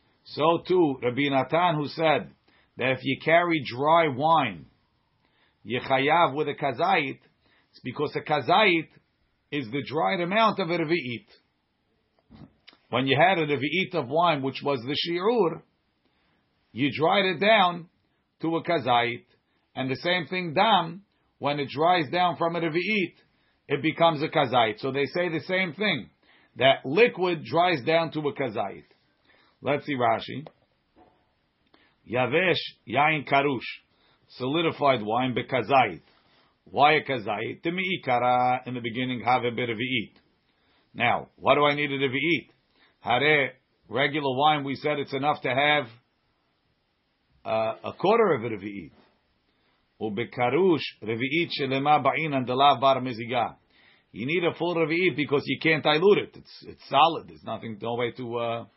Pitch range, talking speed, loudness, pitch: 130-165 Hz, 140 wpm, -25 LUFS, 145 Hz